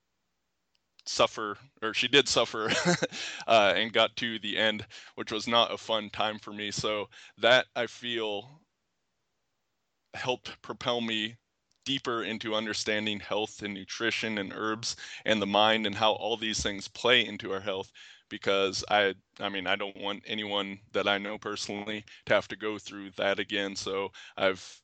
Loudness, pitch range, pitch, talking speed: -29 LUFS, 100-110 Hz, 105 Hz, 160 wpm